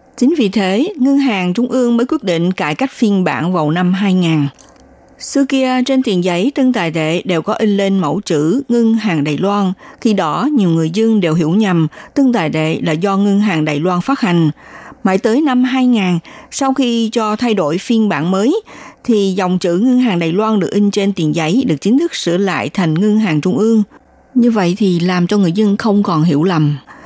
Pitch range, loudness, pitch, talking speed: 175-235 Hz, -14 LUFS, 200 Hz, 220 wpm